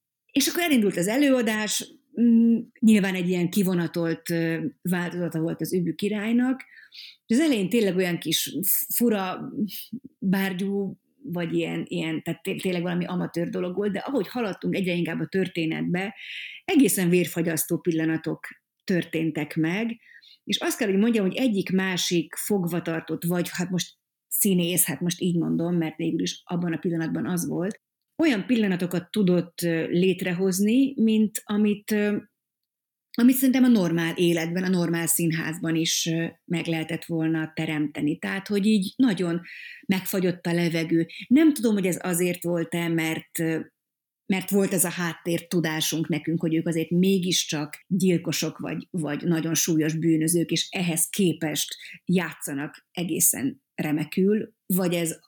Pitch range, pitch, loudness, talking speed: 165-205 Hz, 180 Hz, -25 LUFS, 135 wpm